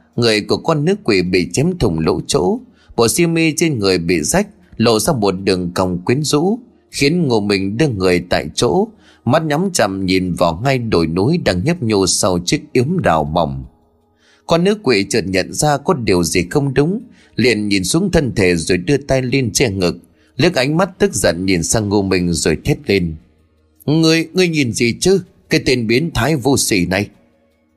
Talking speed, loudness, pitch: 200 wpm, -16 LUFS, 110 Hz